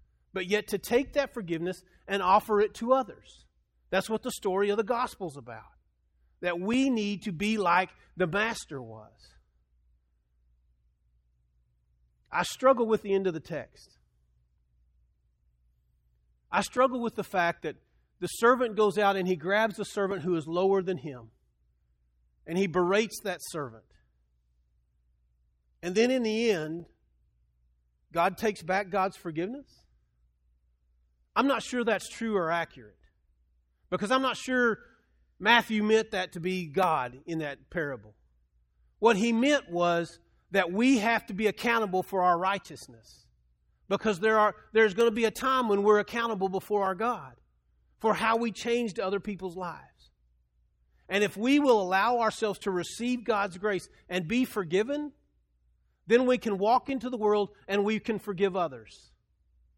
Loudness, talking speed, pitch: -28 LUFS, 150 wpm, 180 Hz